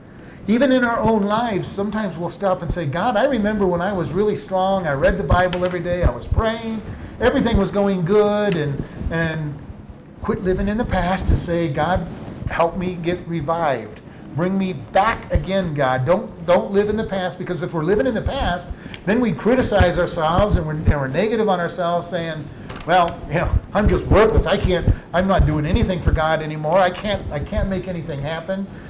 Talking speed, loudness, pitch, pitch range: 200 wpm, -20 LUFS, 180 Hz, 165-200 Hz